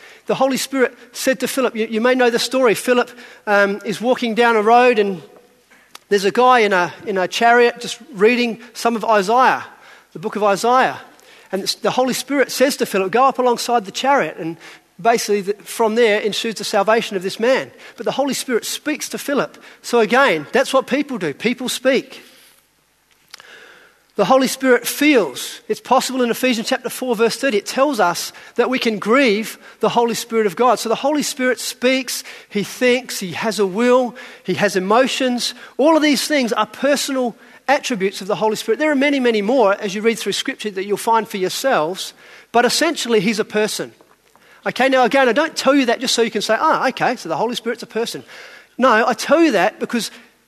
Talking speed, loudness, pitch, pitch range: 205 wpm, -17 LUFS, 235 Hz, 215-255 Hz